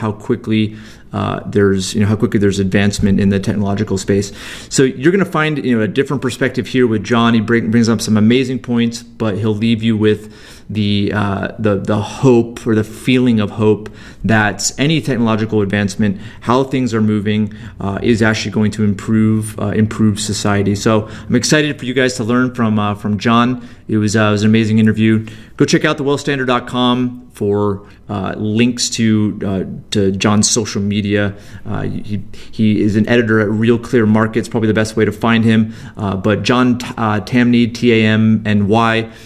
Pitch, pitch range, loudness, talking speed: 110 Hz, 105-120 Hz, -15 LUFS, 200 wpm